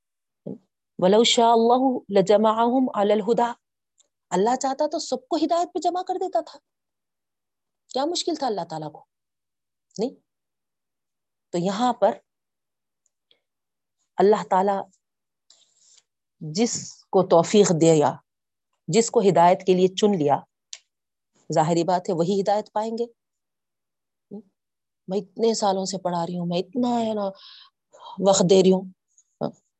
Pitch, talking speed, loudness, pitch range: 205 Hz, 115 wpm, -22 LUFS, 185-240 Hz